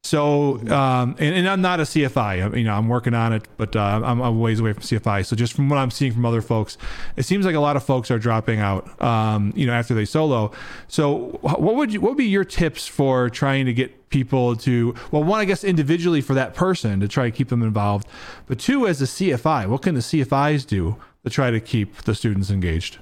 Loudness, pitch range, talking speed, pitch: -21 LUFS, 110-145 Hz, 245 wpm, 125 Hz